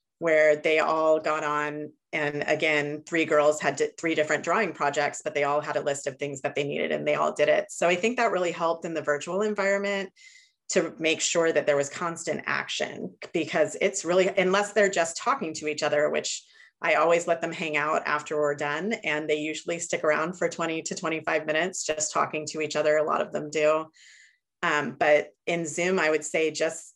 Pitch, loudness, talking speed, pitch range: 155 Hz, -26 LUFS, 215 wpm, 150-170 Hz